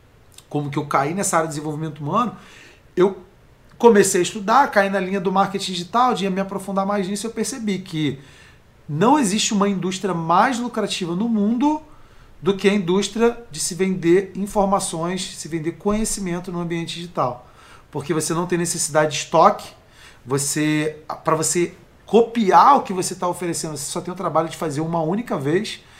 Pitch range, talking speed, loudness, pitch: 160-200 Hz, 175 wpm, -20 LUFS, 180 Hz